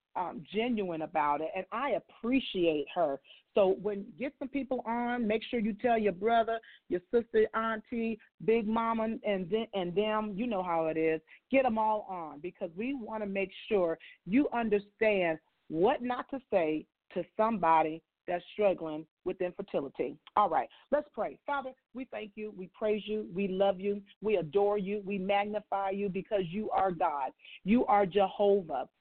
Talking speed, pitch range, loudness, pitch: 170 wpm, 185-225 Hz, -32 LUFS, 205 Hz